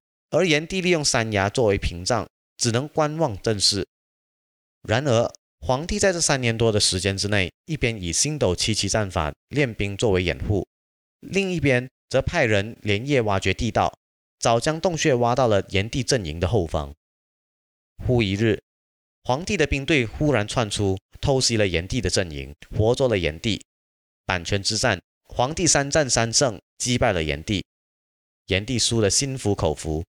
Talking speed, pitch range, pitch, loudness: 240 characters per minute, 90-130 Hz, 105 Hz, -22 LUFS